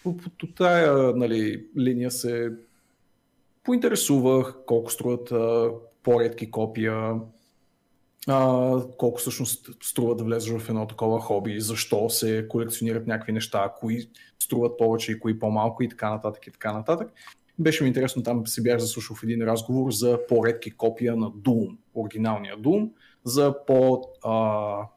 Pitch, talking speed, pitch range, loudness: 115 Hz, 135 wpm, 110-130 Hz, -25 LUFS